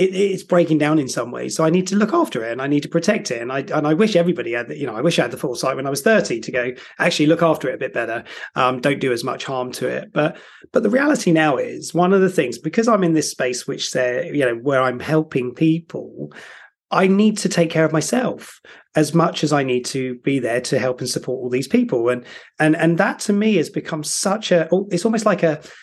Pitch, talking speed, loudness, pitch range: 160 Hz, 270 wpm, -19 LUFS, 130-180 Hz